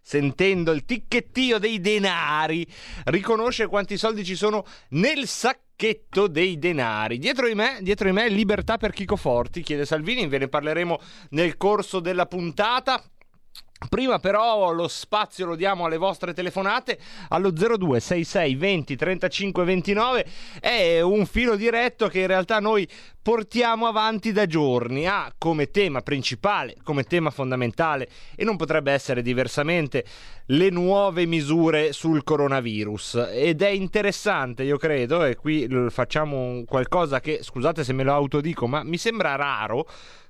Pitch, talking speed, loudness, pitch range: 180 Hz, 140 wpm, -23 LUFS, 150-210 Hz